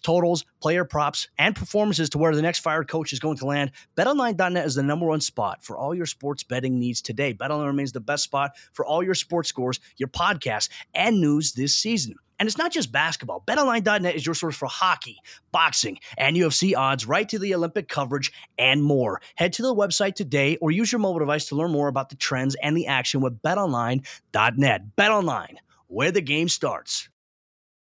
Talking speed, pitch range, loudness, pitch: 200 wpm, 140-180 Hz, -23 LUFS, 155 Hz